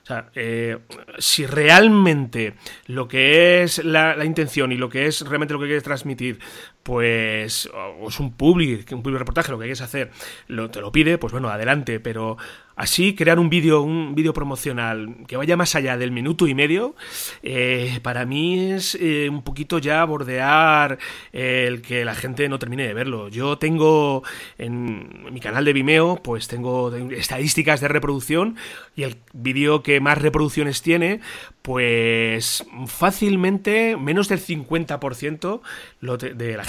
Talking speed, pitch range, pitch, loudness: 165 wpm, 125-160 Hz, 140 Hz, -20 LUFS